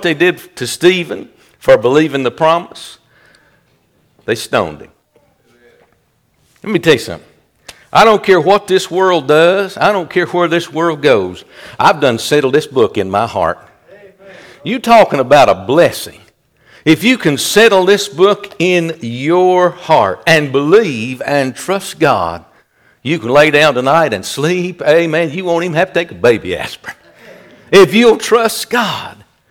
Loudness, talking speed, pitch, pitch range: -12 LUFS, 160 wpm, 175 Hz, 155-195 Hz